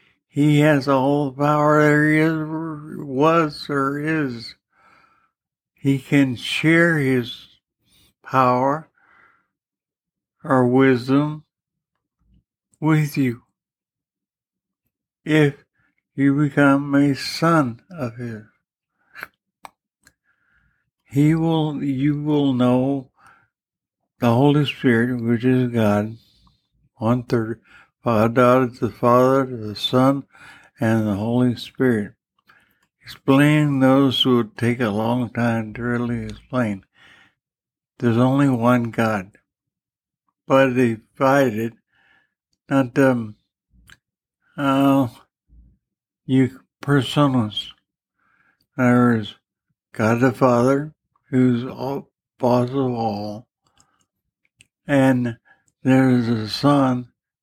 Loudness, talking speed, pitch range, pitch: -19 LUFS, 90 wpm, 120-140 Hz, 130 Hz